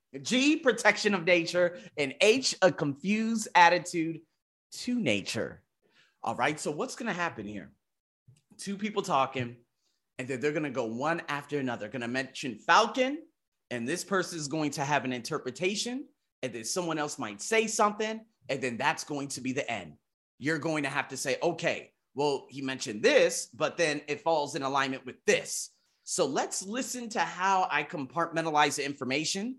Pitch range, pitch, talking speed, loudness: 135-205 Hz, 160 Hz, 175 wpm, -29 LUFS